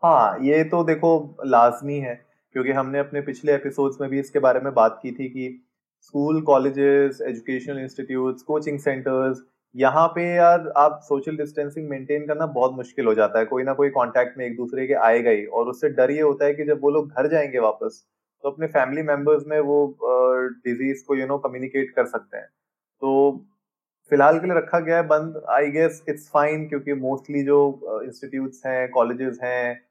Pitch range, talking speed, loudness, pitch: 130-150 Hz, 200 wpm, -22 LUFS, 140 Hz